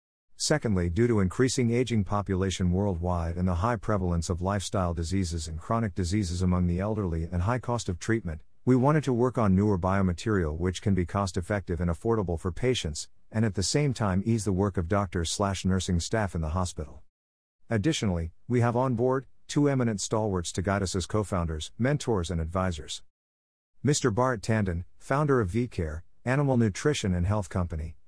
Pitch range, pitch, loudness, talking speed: 90-115 Hz, 95 Hz, -28 LUFS, 180 wpm